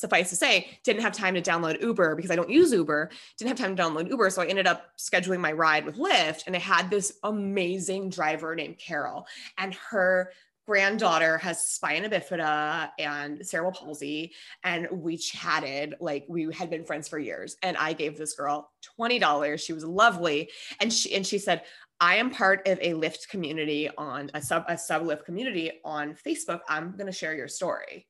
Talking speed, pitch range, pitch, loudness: 200 wpm, 155-190 Hz, 170 Hz, -27 LUFS